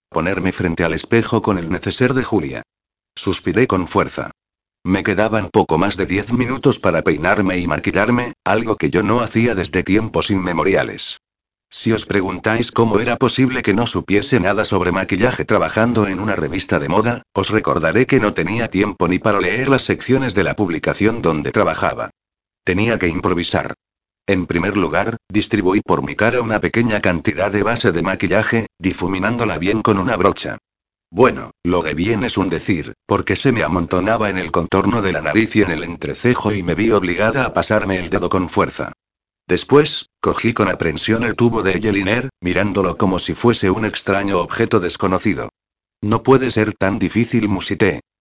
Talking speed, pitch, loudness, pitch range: 175 wpm, 105 Hz, -17 LUFS, 95-115 Hz